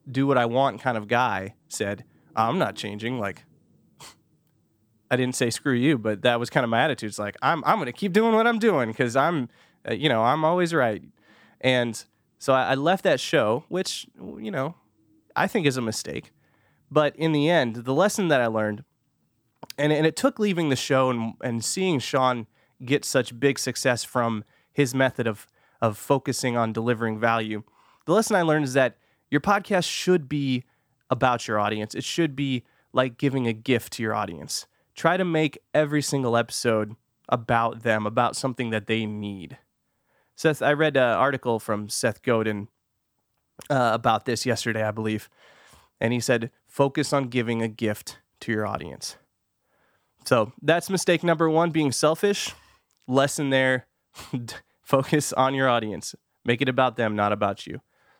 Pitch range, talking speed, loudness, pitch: 115-145 Hz, 175 wpm, -24 LUFS, 130 Hz